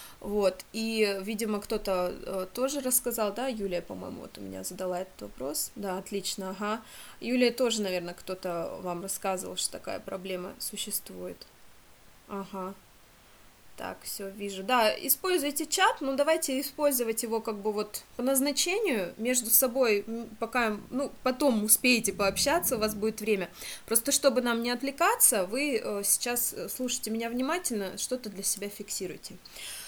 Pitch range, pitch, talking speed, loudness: 195-255 Hz, 220 Hz, 140 wpm, -29 LUFS